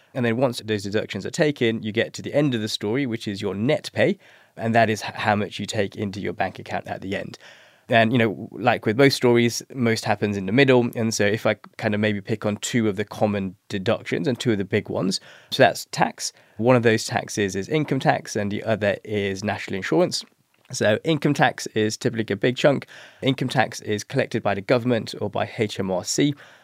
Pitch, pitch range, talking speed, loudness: 110 Hz, 105-120 Hz, 225 wpm, -23 LUFS